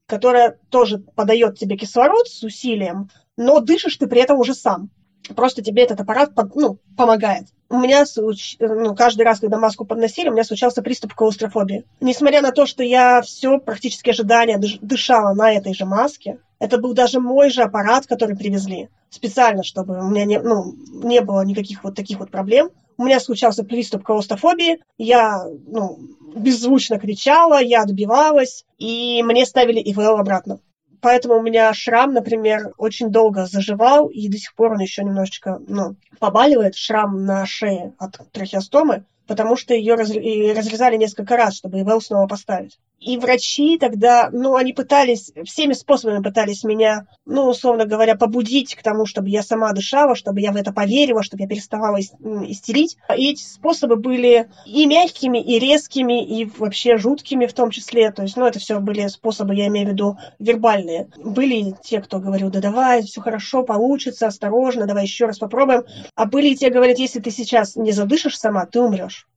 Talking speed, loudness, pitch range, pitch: 170 wpm, -17 LUFS, 210-250 Hz, 225 Hz